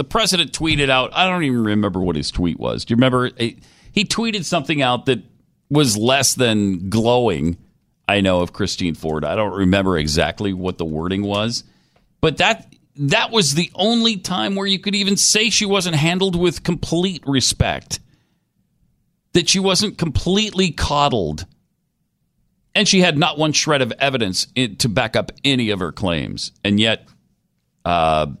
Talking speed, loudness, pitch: 165 wpm, -18 LUFS, 135 Hz